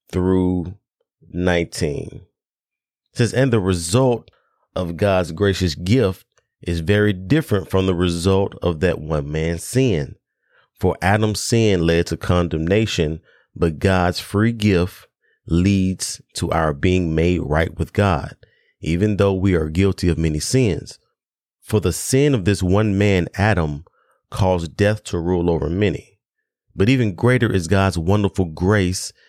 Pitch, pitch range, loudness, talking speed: 95 Hz, 85-105 Hz, -19 LUFS, 140 wpm